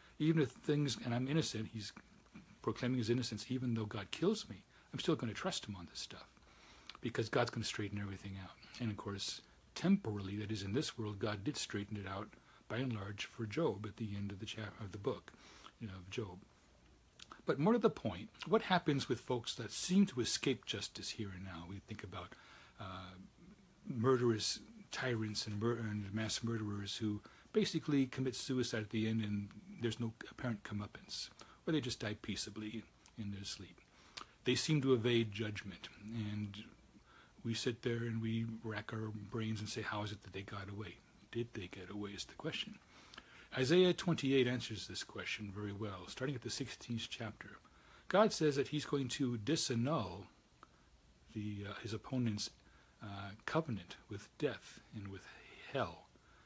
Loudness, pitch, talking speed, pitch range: -40 LUFS, 110 Hz, 180 wpm, 105-125 Hz